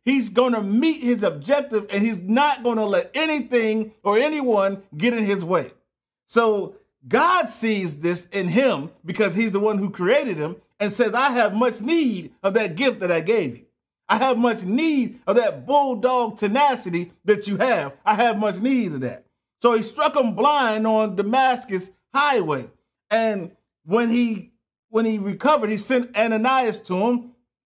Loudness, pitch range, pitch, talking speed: -21 LUFS, 200-255 Hz, 225 Hz, 175 wpm